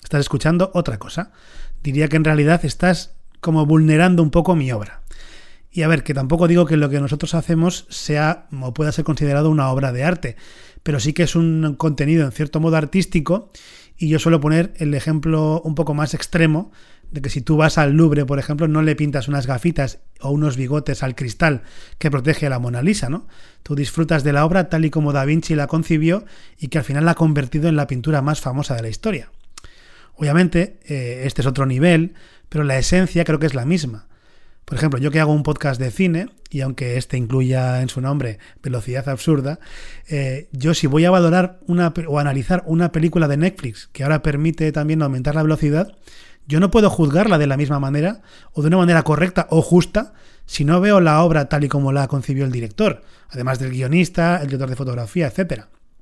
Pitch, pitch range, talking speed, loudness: 155 Hz, 140-165 Hz, 210 wpm, -18 LUFS